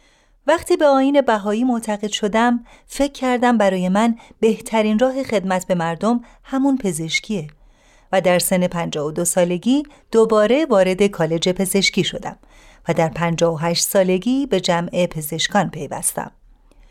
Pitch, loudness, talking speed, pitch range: 210 Hz, -18 LUFS, 125 wpm, 180-250 Hz